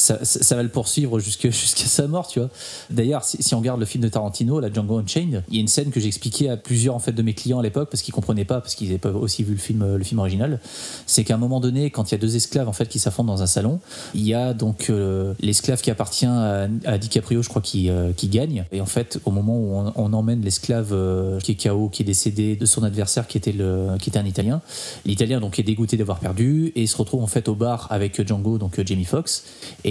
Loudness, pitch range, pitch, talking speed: -21 LUFS, 105-125 Hz, 115 Hz, 275 wpm